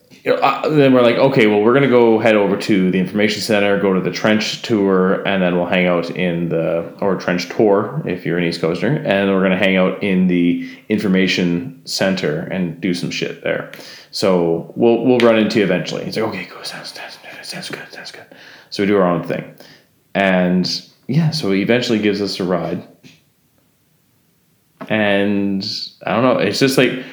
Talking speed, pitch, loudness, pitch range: 200 wpm, 100 Hz, -16 LUFS, 90-110 Hz